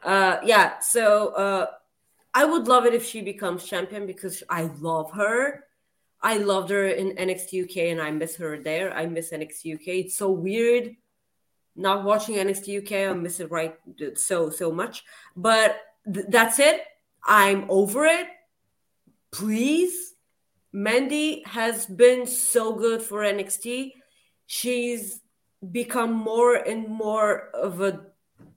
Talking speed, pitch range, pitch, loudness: 140 wpm, 185-235 Hz, 205 Hz, -23 LUFS